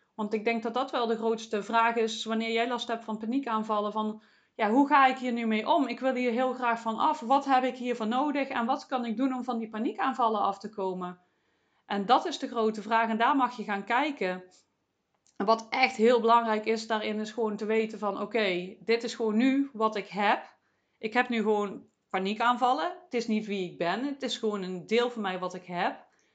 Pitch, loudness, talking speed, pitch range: 225 Hz, -28 LUFS, 235 wpm, 215-250 Hz